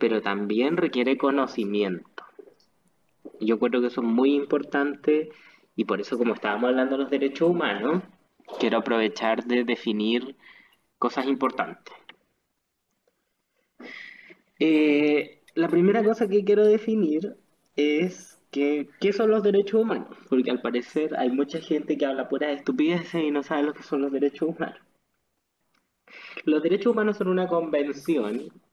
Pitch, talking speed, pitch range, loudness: 145 Hz, 140 wpm, 125-170 Hz, -25 LUFS